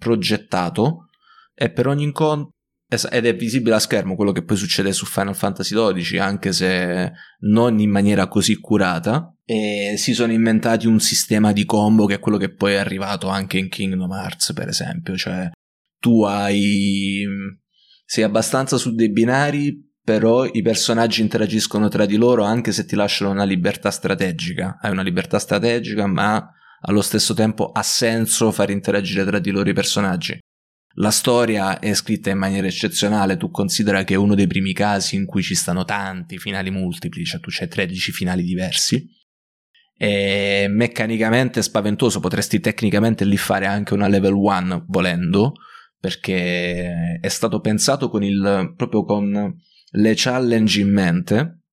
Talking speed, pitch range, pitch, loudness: 160 wpm, 100-115 Hz, 105 Hz, -19 LUFS